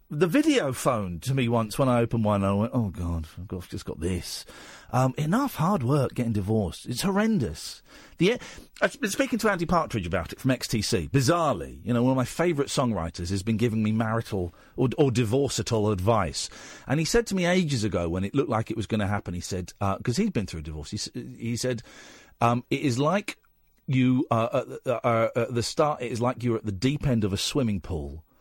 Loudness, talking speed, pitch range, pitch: -26 LUFS, 230 wpm, 100-140 Hz, 115 Hz